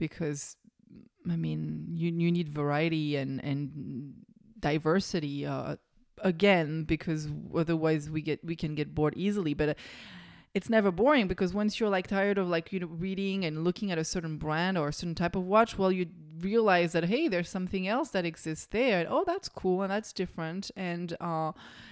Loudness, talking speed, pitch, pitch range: -30 LUFS, 185 wpm, 175 Hz, 155-195 Hz